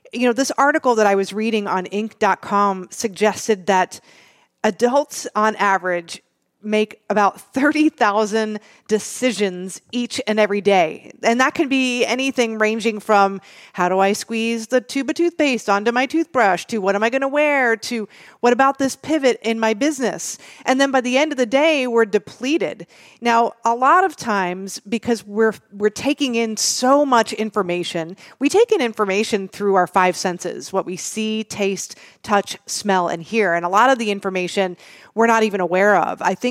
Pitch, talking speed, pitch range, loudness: 220 Hz, 180 wpm, 200-255 Hz, -19 LUFS